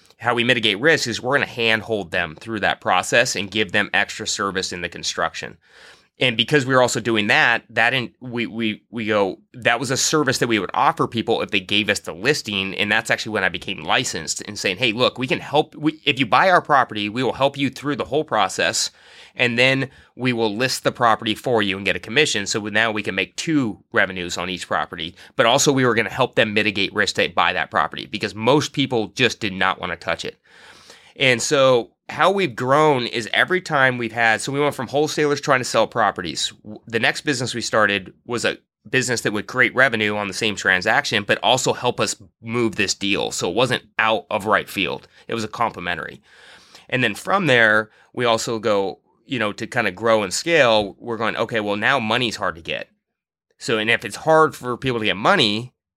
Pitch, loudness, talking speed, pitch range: 115 Hz, -20 LUFS, 225 wpm, 105-130 Hz